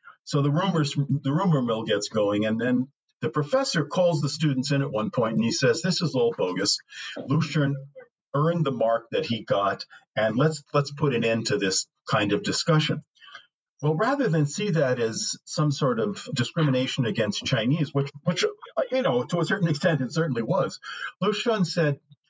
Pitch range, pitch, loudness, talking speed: 135-170 Hz, 150 Hz, -25 LUFS, 190 wpm